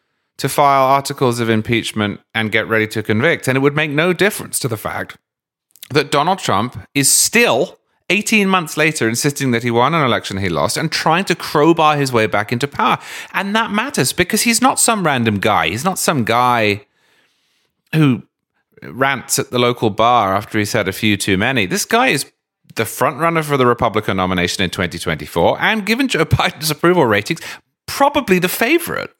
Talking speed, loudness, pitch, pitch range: 185 wpm, -15 LUFS, 135 Hz, 110-170 Hz